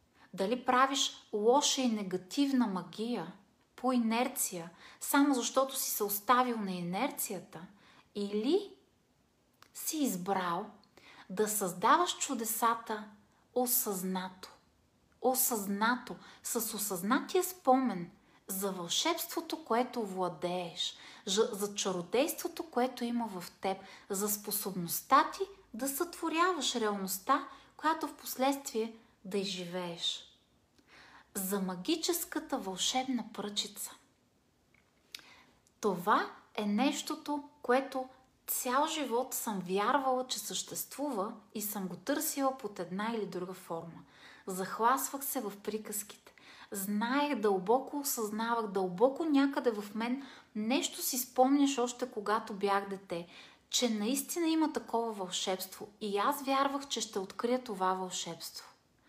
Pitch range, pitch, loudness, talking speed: 200-270 Hz, 230 Hz, -33 LUFS, 105 wpm